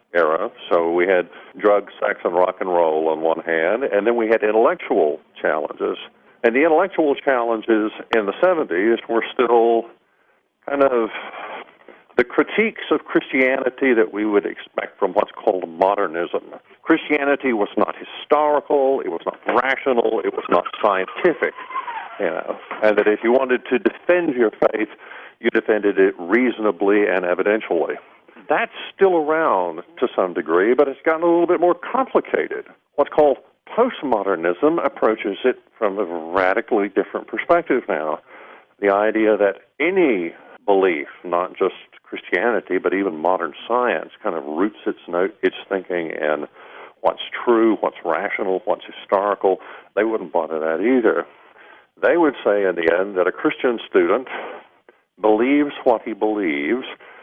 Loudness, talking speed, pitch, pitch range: -20 LUFS, 150 wpm, 115 Hz, 105-150 Hz